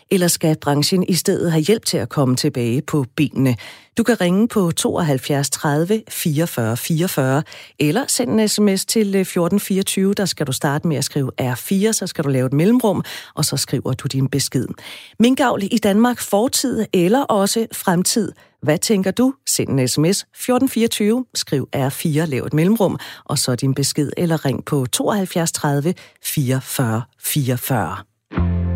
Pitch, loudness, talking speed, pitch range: 160 Hz, -18 LUFS, 160 wpm, 135-200 Hz